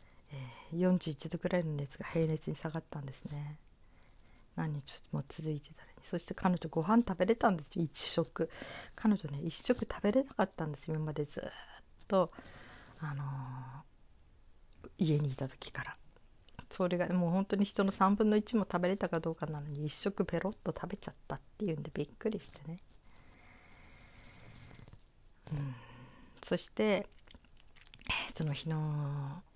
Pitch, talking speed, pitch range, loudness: 155 Hz, 280 characters per minute, 135-180 Hz, -36 LUFS